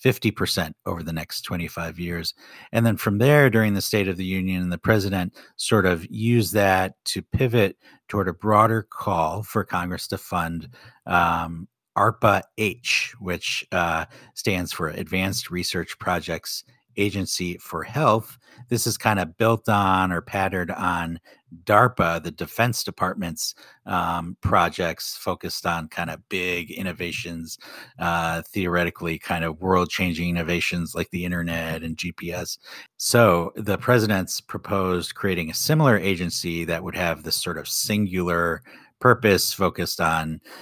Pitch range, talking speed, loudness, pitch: 85-105 Hz, 140 wpm, -23 LUFS, 90 Hz